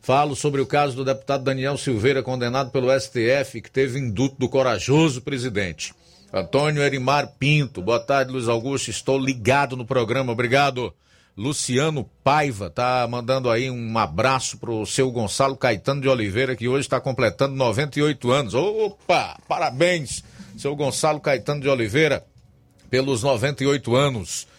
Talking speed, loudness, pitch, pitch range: 145 wpm, -22 LUFS, 135 Hz, 125-140 Hz